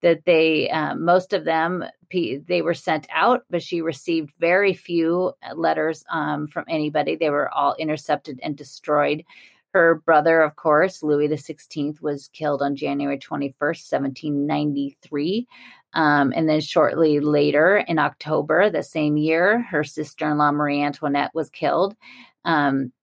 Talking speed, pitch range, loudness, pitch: 145 wpm, 145-170 Hz, -21 LUFS, 155 Hz